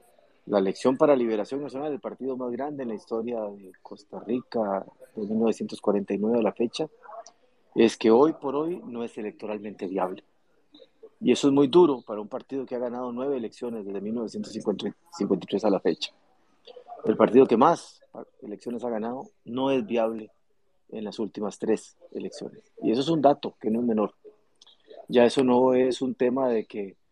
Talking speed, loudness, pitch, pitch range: 175 wpm, -26 LUFS, 120 Hz, 110-135 Hz